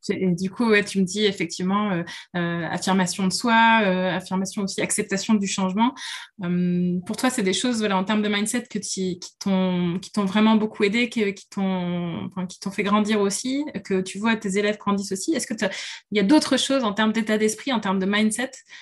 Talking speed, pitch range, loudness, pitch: 220 wpm, 190-220 Hz, -23 LUFS, 205 Hz